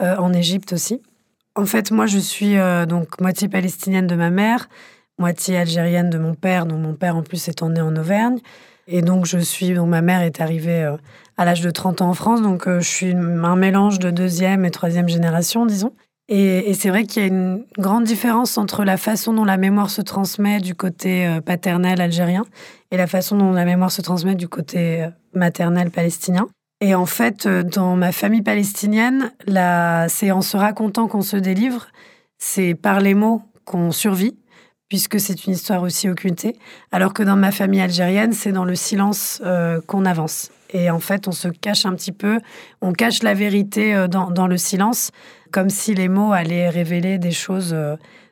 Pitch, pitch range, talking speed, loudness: 185 Hz, 175-205 Hz, 200 wpm, -18 LUFS